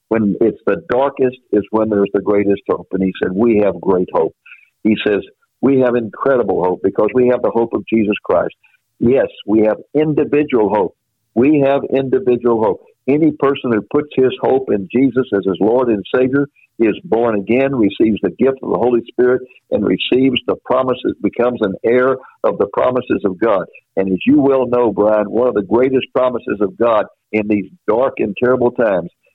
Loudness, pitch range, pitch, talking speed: -16 LUFS, 110-135 Hz, 125 Hz, 190 wpm